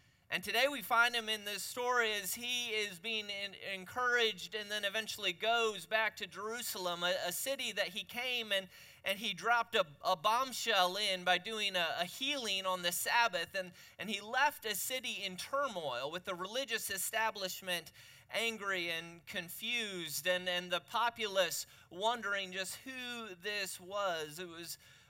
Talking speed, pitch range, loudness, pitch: 165 wpm, 180-230 Hz, -35 LUFS, 205 Hz